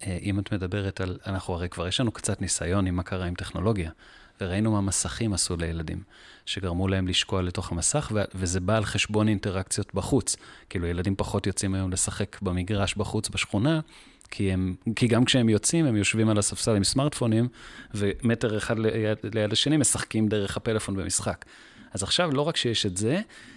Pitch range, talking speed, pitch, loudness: 95-110 Hz, 175 wpm, 105 Hz, -26 LUFS